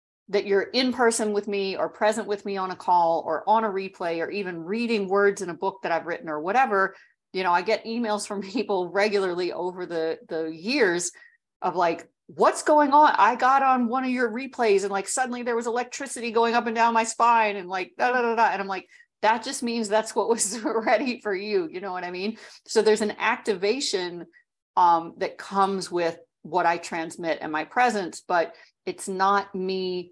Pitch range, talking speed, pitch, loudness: 180-235 Hz, 210 wpm, 205 Hz, -24 LUFS